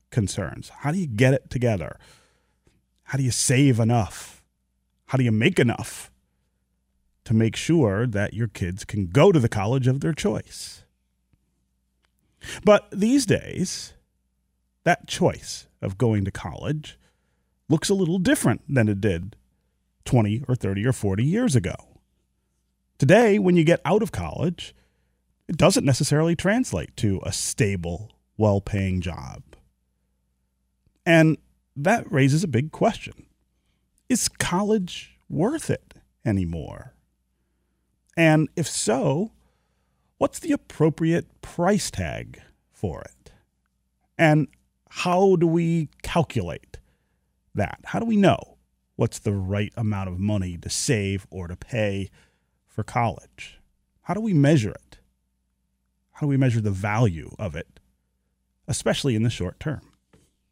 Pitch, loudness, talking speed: 105 Hz, -23 LUFS, 130 wpm